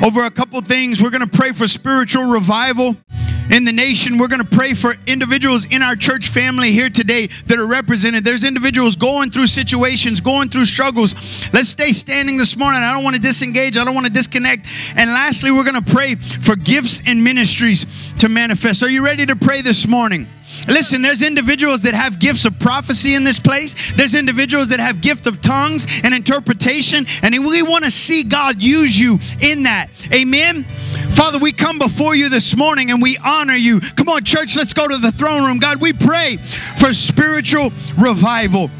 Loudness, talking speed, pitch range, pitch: -13 LUFS, 190 wpm, 230-275 Hz, 255 Hz